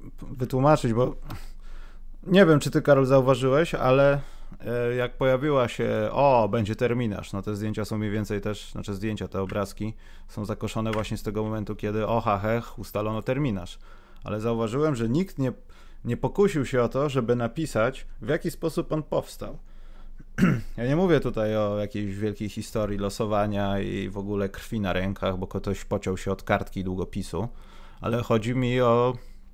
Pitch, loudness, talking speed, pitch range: 110 Hz, -26 LUFS, 165 wpm, 100-130 Hz